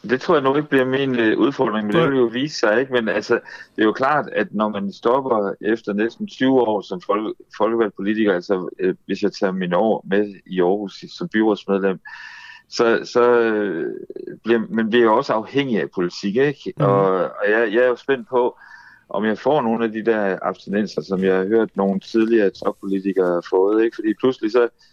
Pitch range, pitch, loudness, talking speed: 100-125 Hz, 110 Hz, -20 LUFS, 200 wpm